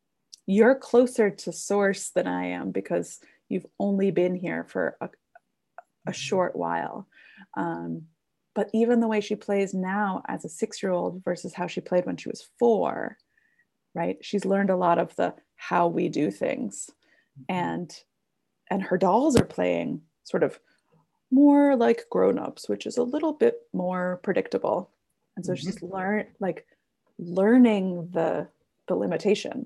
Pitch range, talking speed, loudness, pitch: 180-230 Hz, 155 wpm, -26 LUFS, 195 Hz